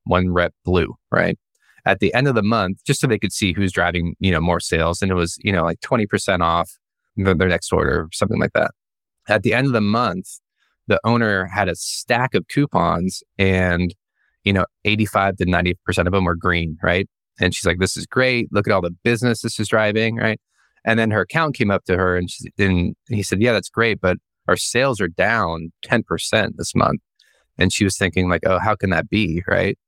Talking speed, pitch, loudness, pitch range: 225 wpm, 95 Hz, -19 LUFS, 90-110 Hz